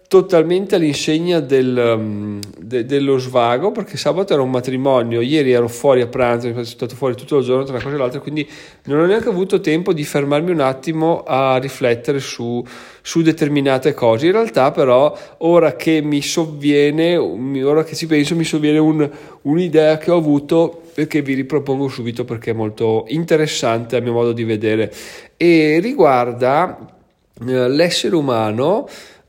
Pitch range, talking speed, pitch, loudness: 125-160 Hz, 165 wpm, 140 Hz, -16 LUFS